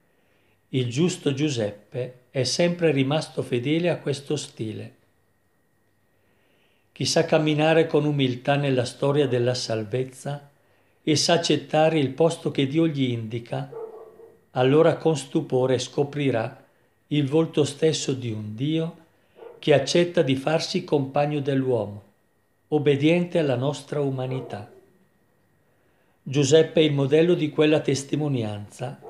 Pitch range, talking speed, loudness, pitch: 125-160 Hz, 115 wpm, -23 LUFS, 145 Hz